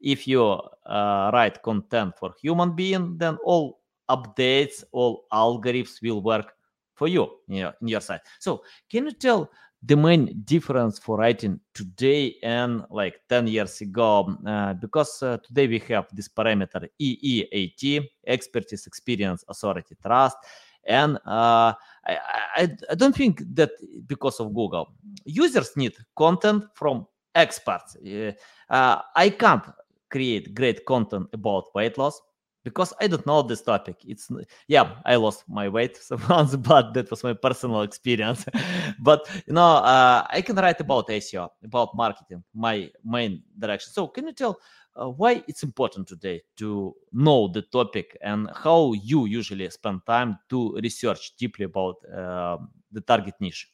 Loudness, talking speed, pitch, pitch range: -23 LUFS, 150 wpm, 120 Hz, 105-150 Hz